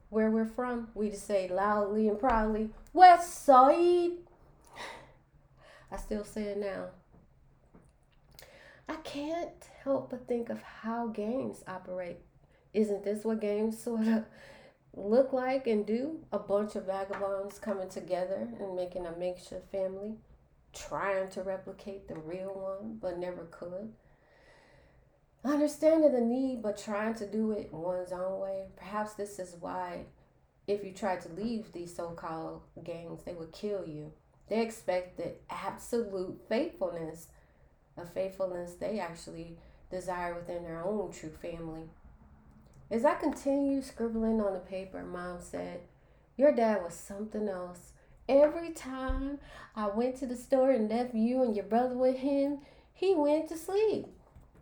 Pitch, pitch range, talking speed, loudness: 205 Hz, 180-245 Hz, 145 wpm, -32 LUFS